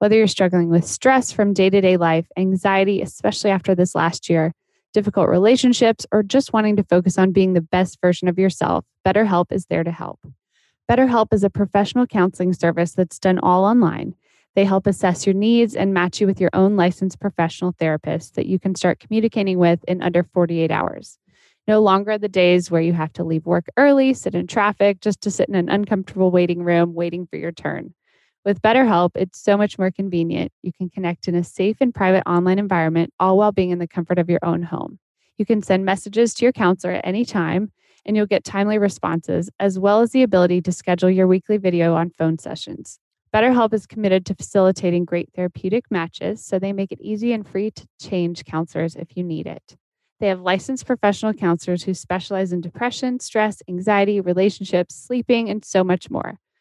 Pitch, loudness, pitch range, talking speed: 190 Hz, -19 LUFS, 175-210 Hz, 200 wpm